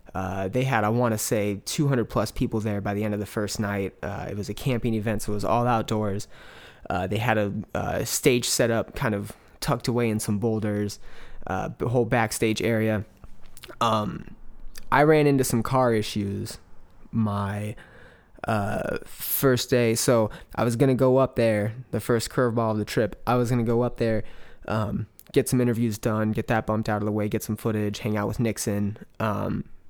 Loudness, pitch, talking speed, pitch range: -25 LUFS, 110 Hz, 205 wpm, 105-120 Hz